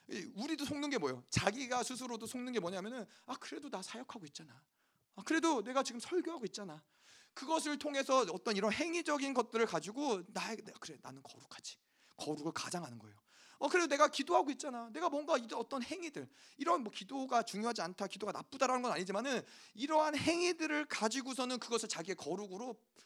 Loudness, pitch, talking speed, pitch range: -38 LUFS, 245 Hz, 415 characters per minute, 200-290 Hz